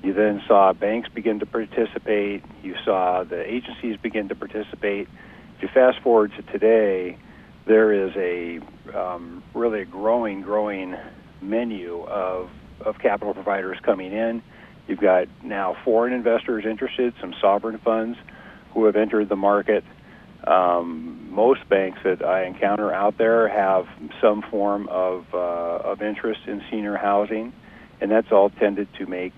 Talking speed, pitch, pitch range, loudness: 150 wpm, 100 Hz, 95-110 Hz, -22 LUFS